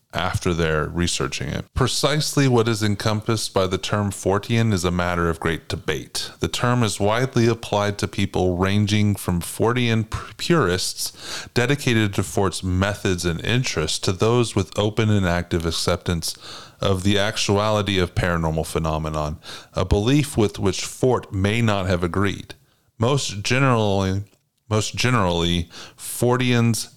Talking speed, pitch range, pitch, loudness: 140 wpm, 90-115 Hz, 105 Hz, -21 LUFS